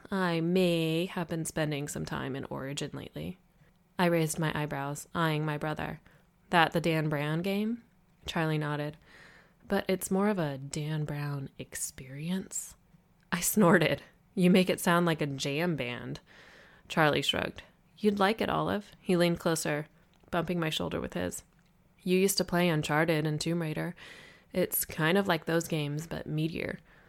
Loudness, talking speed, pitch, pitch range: -30 LUFS, 160 wpm, 165 Hz, 155-180 Hz